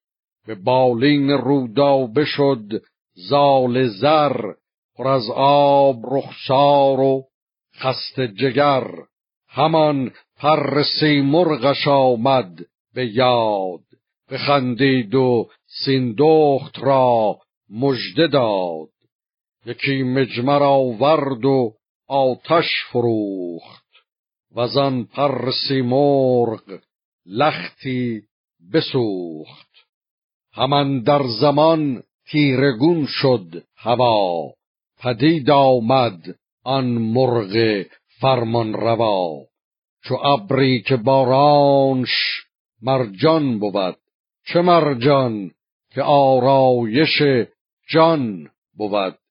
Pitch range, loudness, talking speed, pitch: 120-140 Hz, -17 LUFS, 80 wpm, 135 Hz